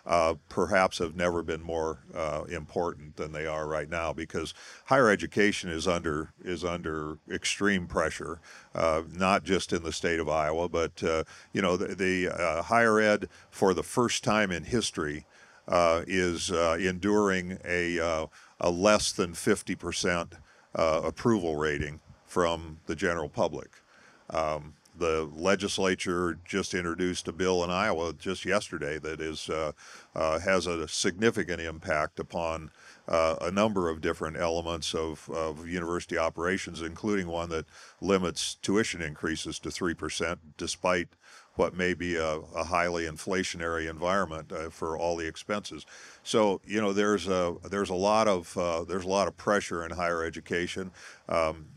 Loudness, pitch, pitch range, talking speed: -29 LUFS, 85 Hz, 80-95 Hz, 155 wpm